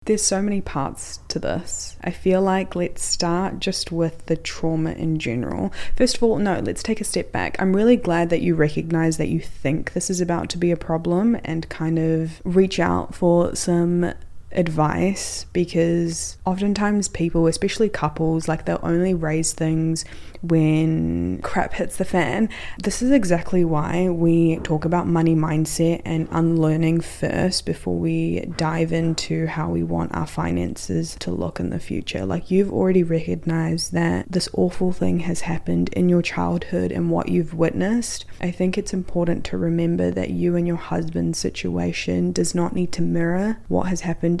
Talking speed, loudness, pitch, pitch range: 175 wpm, -22 LUFS, 165 Hz, 155-180 Hz